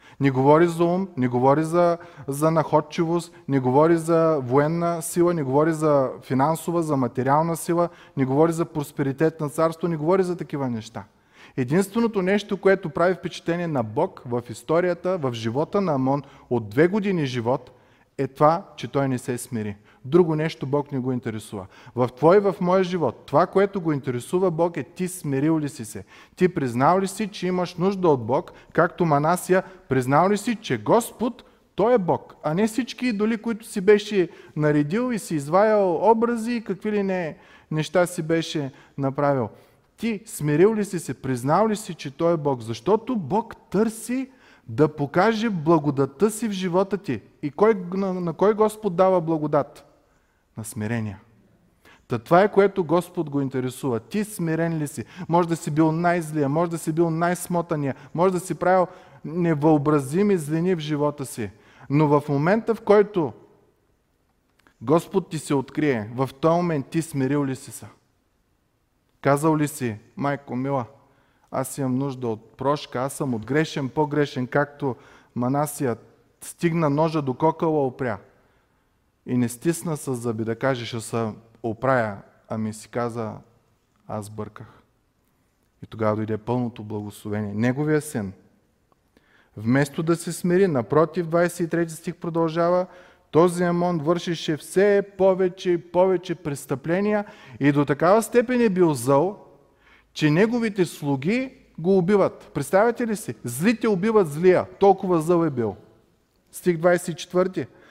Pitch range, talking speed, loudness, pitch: 130-180 Hz, 155 wpm, -23 LUFS, 155 Hz